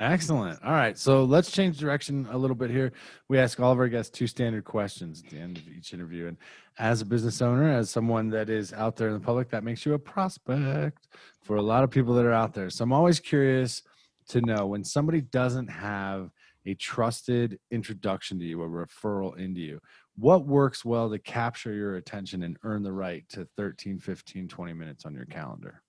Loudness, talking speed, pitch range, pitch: -27 LUFS, 215 wpm, 95-130 Hz, 115 Hz